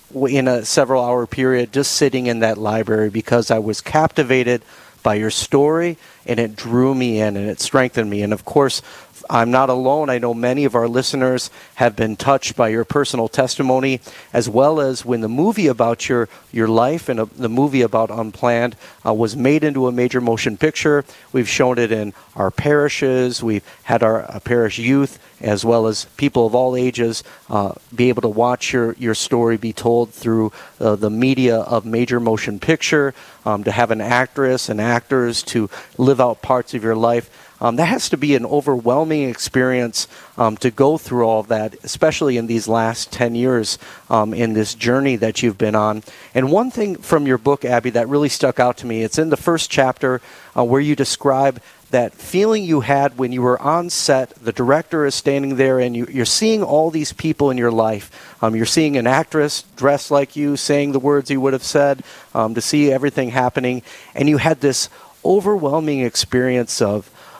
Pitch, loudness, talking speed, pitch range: 125 Hz, -18 LUFS, 200 wpm, 115-140 Hz